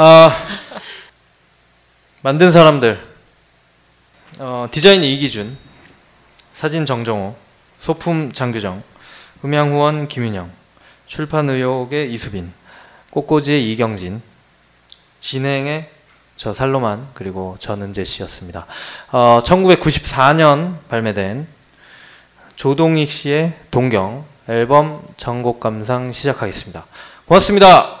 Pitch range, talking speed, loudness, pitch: 110-150 Hz, 200 characters per minute, -15 LUFS, 135 Hz